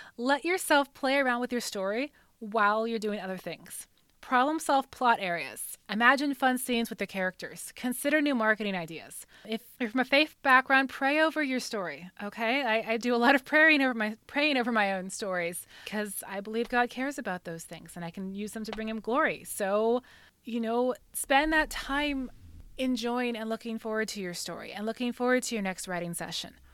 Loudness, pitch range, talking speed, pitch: -28 LUFS, 200-260 Hz, 200 wpm, 230 Hz